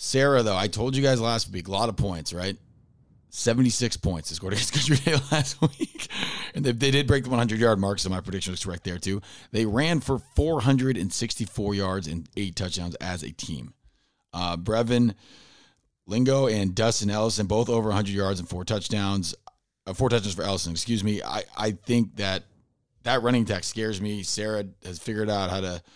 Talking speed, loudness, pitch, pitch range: 190 wpm, -26 LUFS, 105 Hz, 95-120 Hz